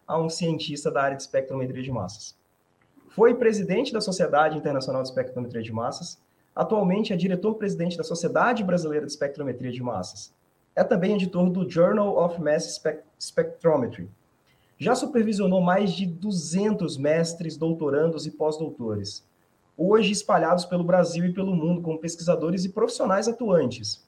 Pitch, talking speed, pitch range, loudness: 170 Hz, 145 wpm, 145-190 Hz, -25 LUFS